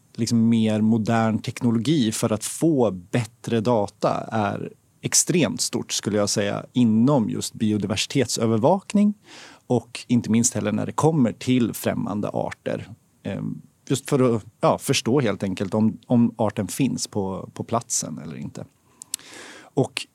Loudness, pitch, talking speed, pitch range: -23 LUFS, 115 Hz, 135 wpm, 105-125 Hz